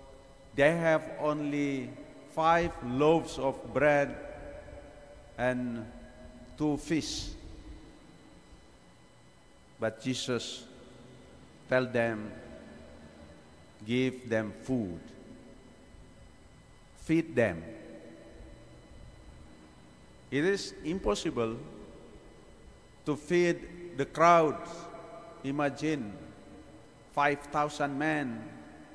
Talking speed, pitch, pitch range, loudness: 60 wpm, 130 Hz, 110-150 Hz, -31 LUFS